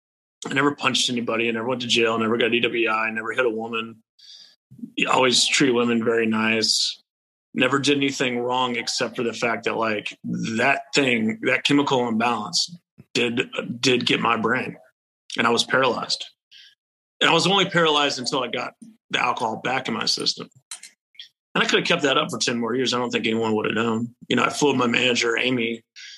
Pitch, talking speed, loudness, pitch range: 120 Hz, 195 wpm, -21 LUFS, 115-140 Hz